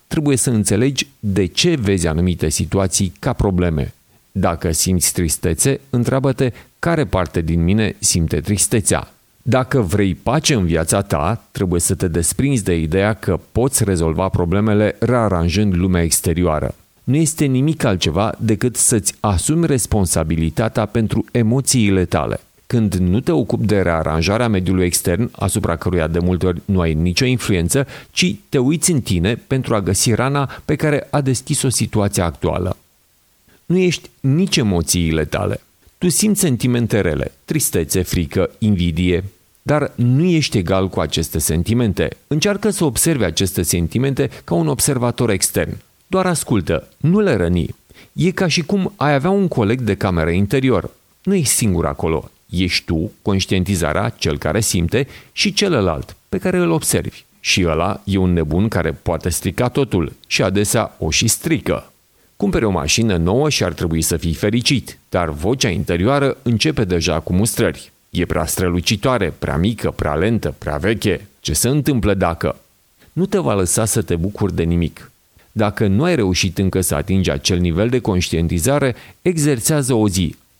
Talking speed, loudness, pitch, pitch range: 155 wpm, -17 LUFS, 105 Hz, 90-130 Hz